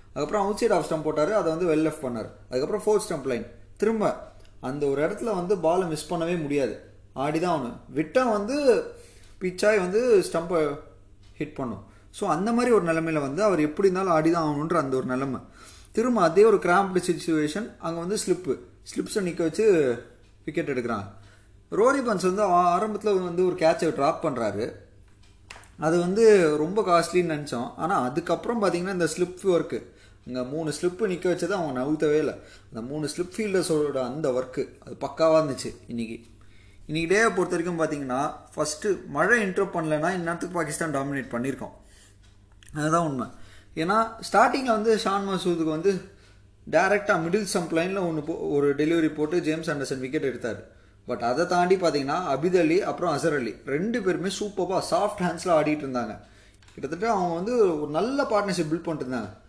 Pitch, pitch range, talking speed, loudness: 160 Hz, 130-190 Hz, 155 wpm, -25 LUFS